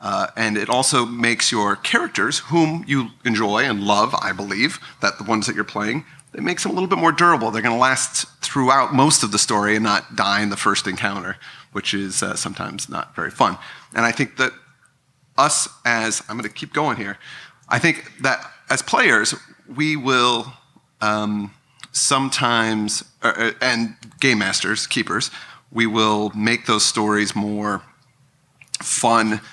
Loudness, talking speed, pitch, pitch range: -19 LUFS, 170 wpm, 115 Hz, 105-135 Hz